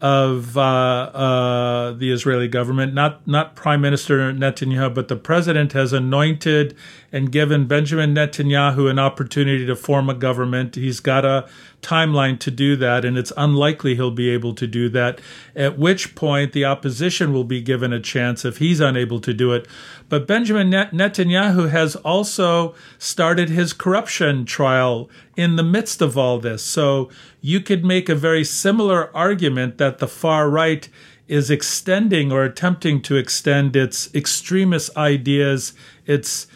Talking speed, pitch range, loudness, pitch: 160 wpm, 130-160 Hz, -18 LUFS, 140 Hz